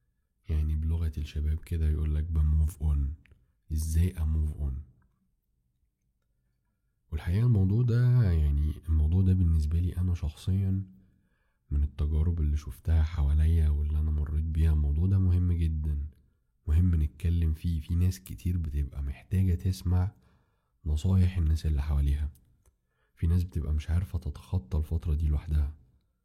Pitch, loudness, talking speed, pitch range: 80 Hz, -29 LUFS, 130 wpm, 75-90 Hz